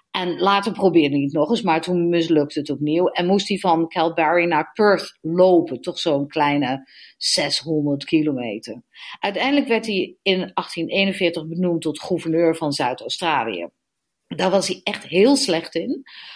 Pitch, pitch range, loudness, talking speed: 170 Hz, 150-190 Hz, -20 LUFS, 160 wpm